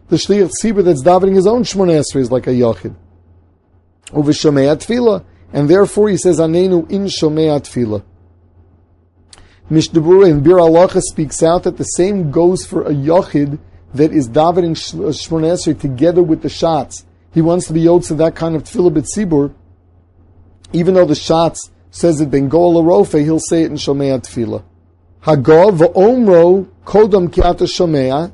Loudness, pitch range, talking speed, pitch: -12 LUFS, 120-175 Hz, 150 wpm, 160 Hz